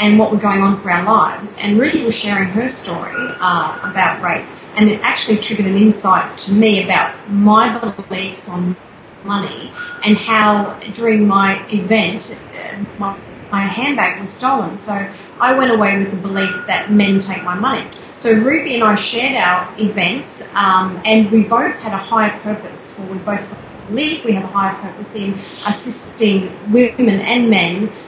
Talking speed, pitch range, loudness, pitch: 175 wpm, 195-220 Hz, -15 LUFS, 210 Hz